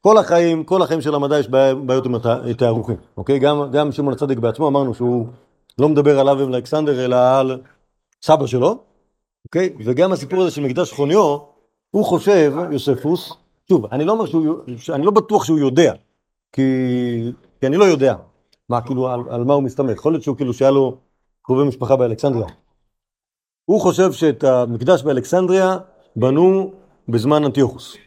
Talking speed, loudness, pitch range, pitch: 160 wpm, -17 LUFS, 125-160 Hz, 140 Hz